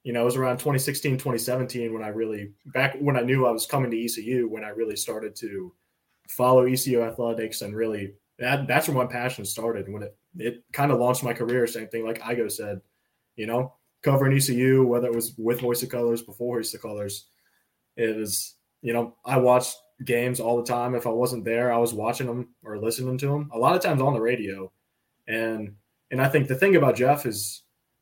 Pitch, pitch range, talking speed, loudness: 120 Hz, 115-130 Hz, 215 wpm, -25 LUFS